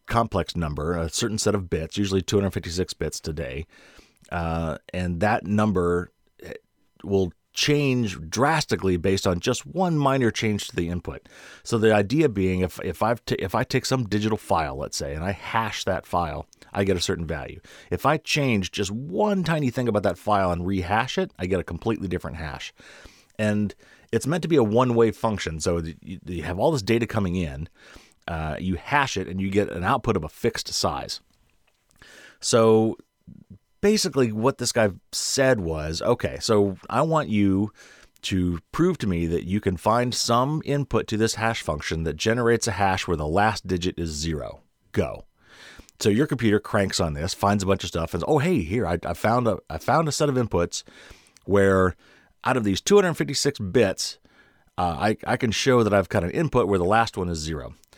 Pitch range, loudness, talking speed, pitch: 90-120 Hz, -24 LUFS, 195 wpm, 100 Hz